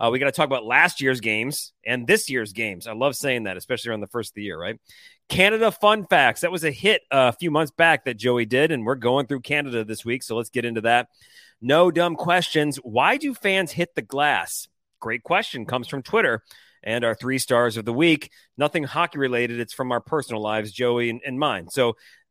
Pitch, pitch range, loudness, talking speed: 130 Hz, 120-160 Hz, -22 LUFS, 230 wpm